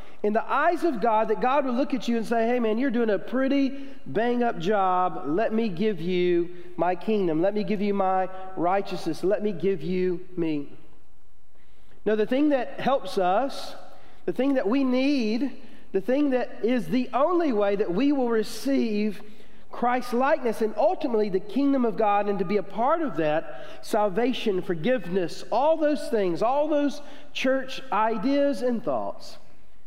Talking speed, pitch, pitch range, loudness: 175 wpm, 220 Hz, 195-265 Hz, -25 LUFS